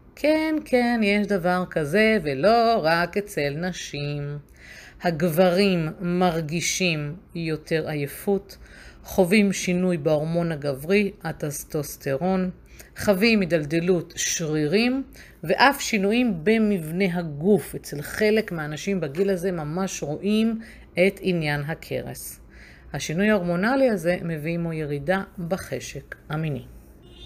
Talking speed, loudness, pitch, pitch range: 95 wpm, -23 LUFS, 180 Hz, 155-205 Hz